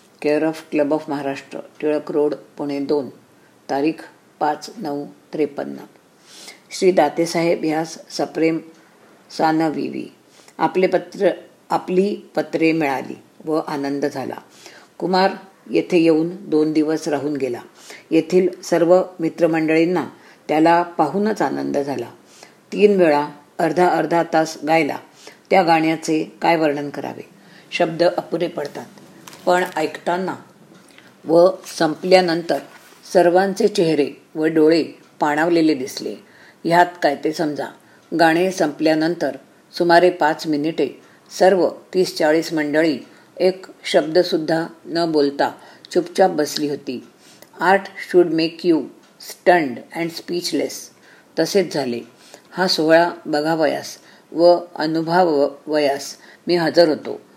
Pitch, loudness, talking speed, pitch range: 160 Hz, -19 LUFS, 110 wpm, 155-175 Hz